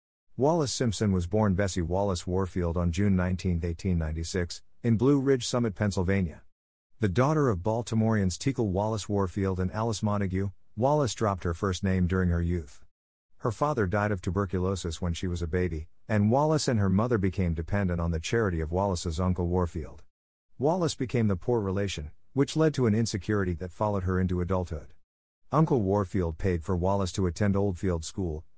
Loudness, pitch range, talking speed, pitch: -28 LUFS, 90-110 Hz, 170 wpm, 95 Hz